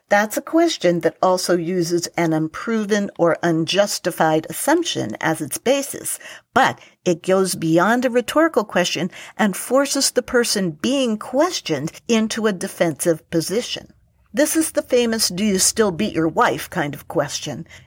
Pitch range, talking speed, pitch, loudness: 170-245 Hz, 150 wpm, 200 Hz, -19 LUFS